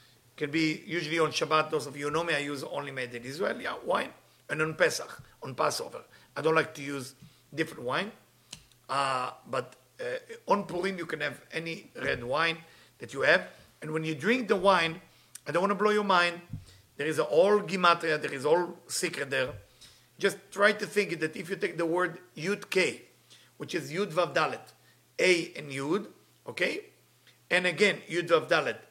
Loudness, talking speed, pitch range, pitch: -29 LUFS, 190 wpm, 150-195 Hz, 165 Hz